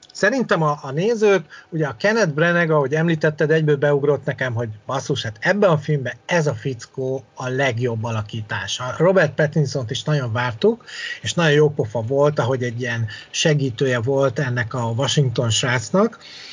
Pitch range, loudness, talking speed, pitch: 125-160 Hz, -20 LUFS, 165 wpm, 145 Hz